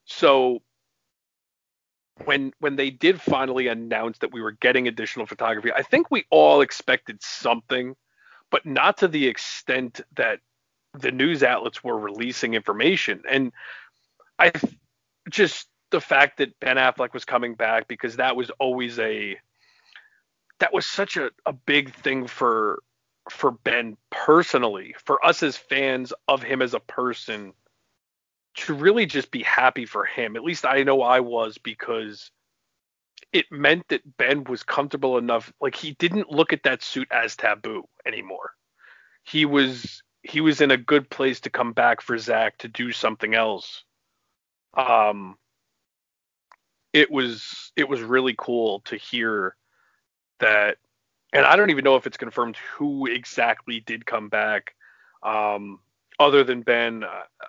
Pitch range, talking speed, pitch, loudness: 115-135 Hz, 150 wpm, 125 Hz, -22 LUFS